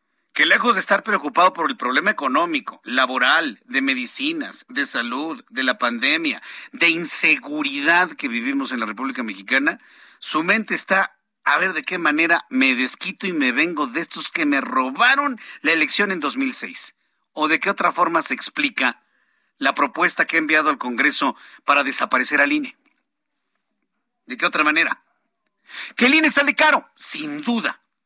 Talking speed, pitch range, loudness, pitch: 165 wpm, 205-295 Hz, -19 LUFS, 270 Hz